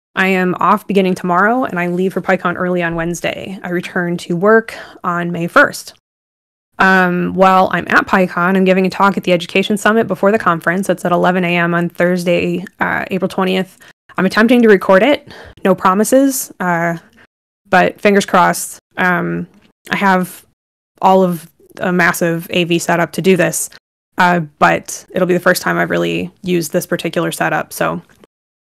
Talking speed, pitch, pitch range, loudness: 170 wpm, 180 Hz, 175-190 Hz, -14 LUFS